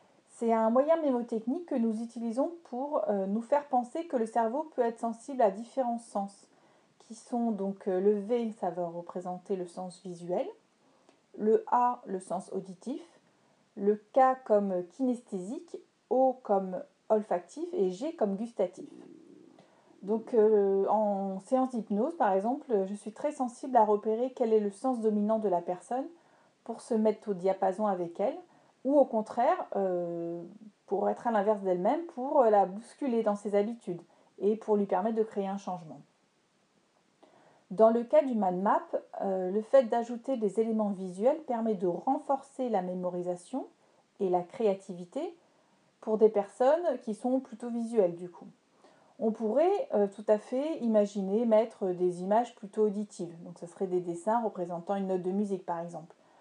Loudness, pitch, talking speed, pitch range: -30 LUFS, 215 Hz, 155 wpm, 195-255 Hz